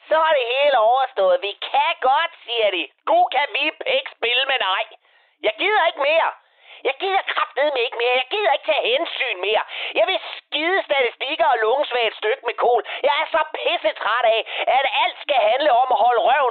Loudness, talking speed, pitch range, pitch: -19 LUFS, 205 wpm, 255-345 Hz, 310 Hz